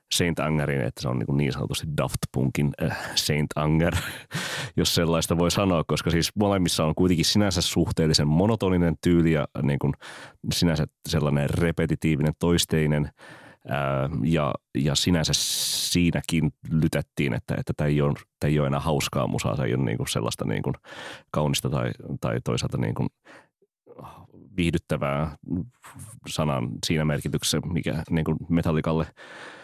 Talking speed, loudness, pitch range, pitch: 140 wpm, -25 LUFS, 75-85 Hz, 80 Hz